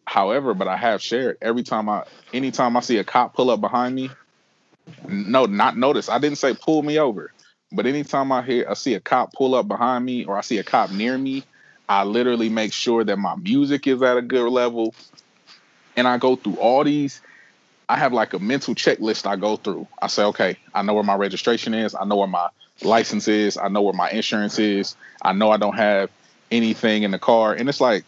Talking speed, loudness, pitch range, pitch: 225 wpm, -21 LUFS, 105-130 Hz, 120 Hz